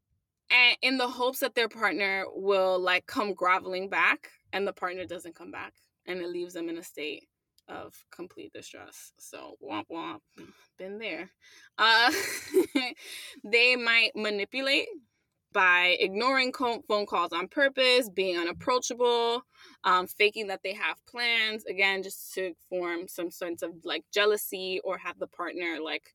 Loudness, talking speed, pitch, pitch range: -27 LUFS, 150 wpm, 205 Hz, 180-250 Hz